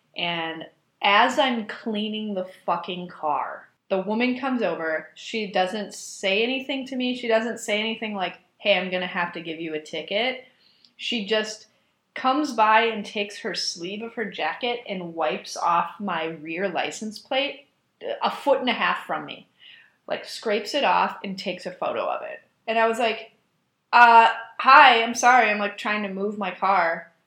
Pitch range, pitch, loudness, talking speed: 180-230 Hz, 210 Hz, -23 LUFS, 180 wpm